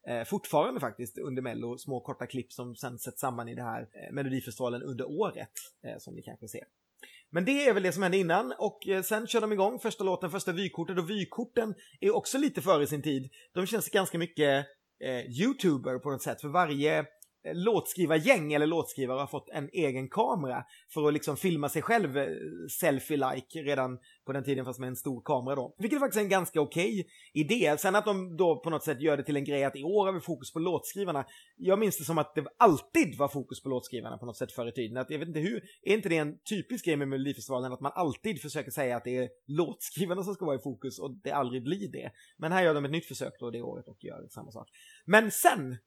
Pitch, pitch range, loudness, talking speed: 150 Hz, 130-190 Hz, -31 LUFS, 230 wpm